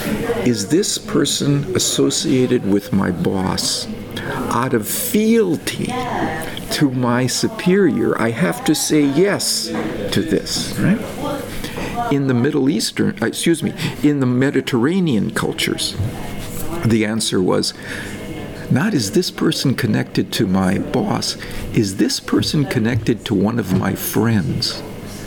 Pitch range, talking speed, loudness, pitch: 110-150 Hz, 120 wpm, -18 LUFS, 125 Hz